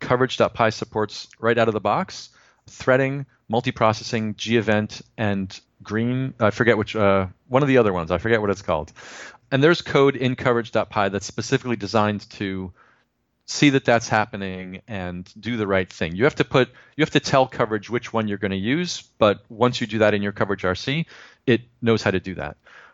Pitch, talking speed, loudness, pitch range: 110 Hz, 195 wpm, -22 LUFS, 100-125 Hz